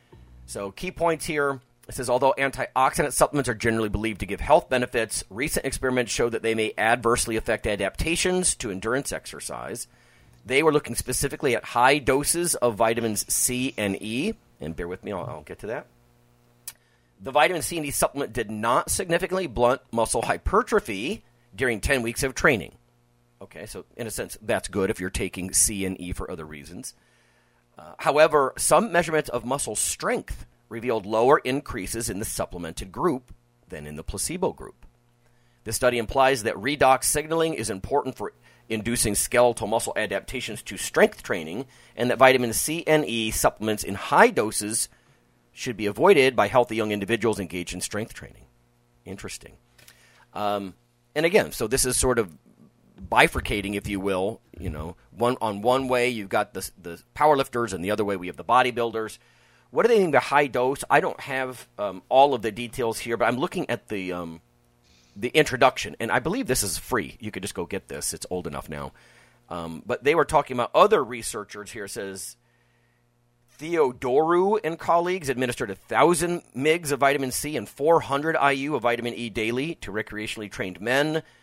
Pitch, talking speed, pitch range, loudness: 120 Hz, 180 wpm, 100-130 Hz, -24 LUFS